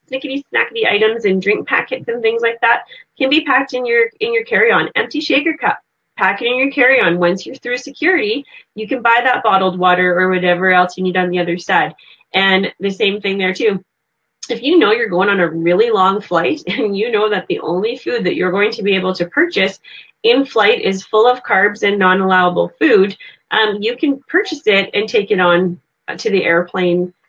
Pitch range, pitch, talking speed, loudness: 185-275 Hz, 210 Hz, 220 wpm, -15 LUFS